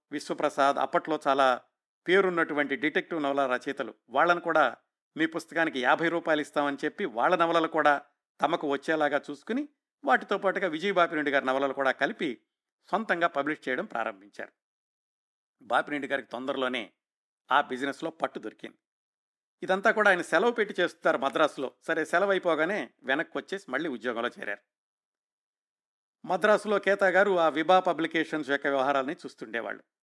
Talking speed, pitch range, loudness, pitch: 130 wpm, 135-175 Hz, -28 LUFS, 155 Hz